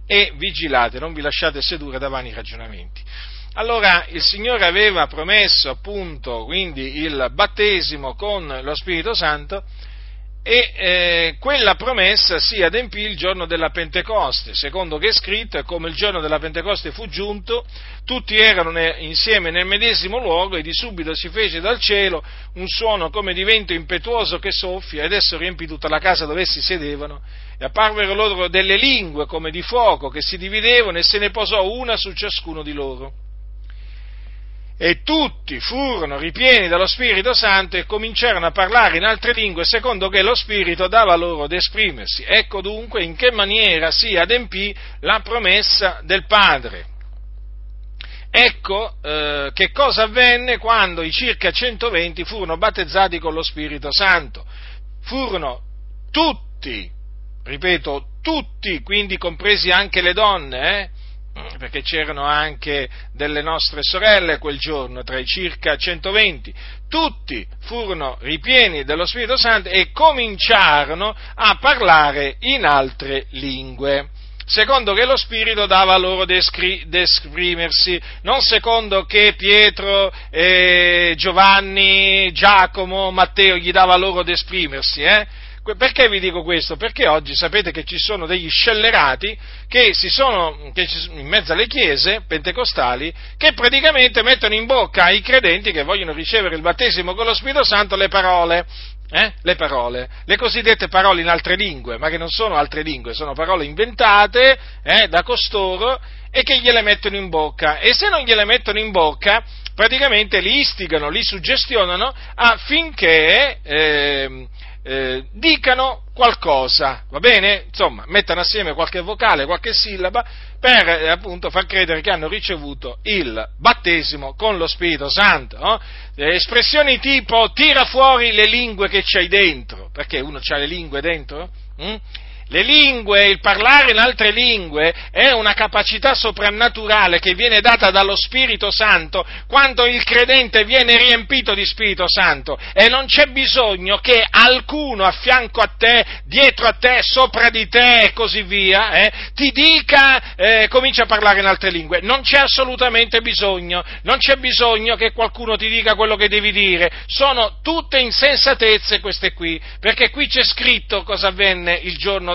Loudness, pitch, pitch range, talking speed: -14 LUFS, 195 Hz, 165-230 Hz, 150 wpm